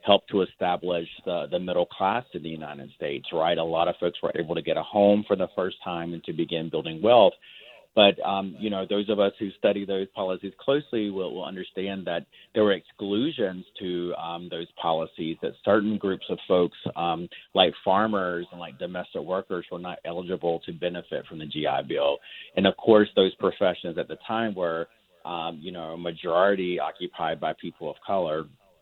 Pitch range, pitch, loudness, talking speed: 85-100 Hz, 90 Hz, -26 LUFS, 195 wpm